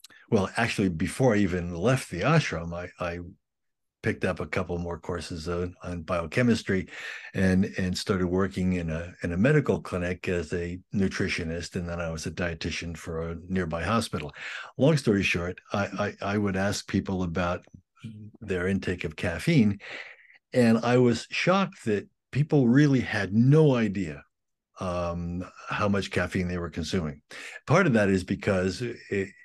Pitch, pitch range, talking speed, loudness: 95 Hz, 90-105 Hz, 160 wpm, -27 LUFS